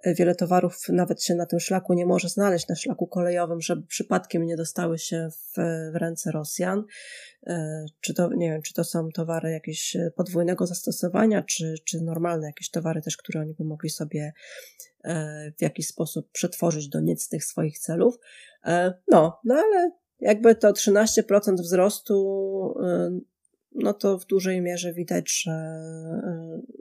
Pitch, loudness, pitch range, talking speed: 175 Hz, -25 LUFS, 160-190 Hz, 160 wpm